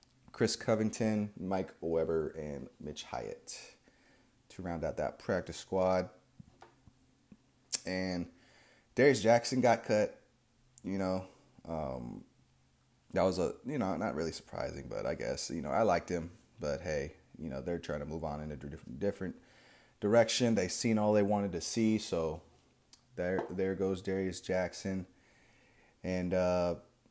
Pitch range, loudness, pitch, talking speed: 85-110 Hz, -34 LUFS, 95 Hz, 145 wpm